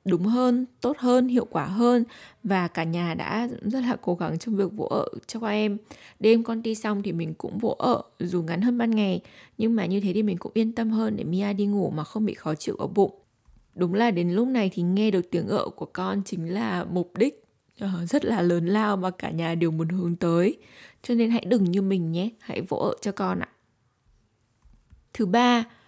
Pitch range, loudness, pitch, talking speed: 180-230 Hz, -25 LUFS, 205 Hz, 230 wpm